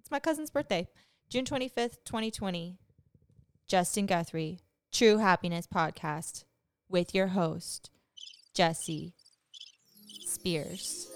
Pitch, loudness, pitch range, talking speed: 180 Hz, -32 LUFS, 165-210 Hz, 90 wpm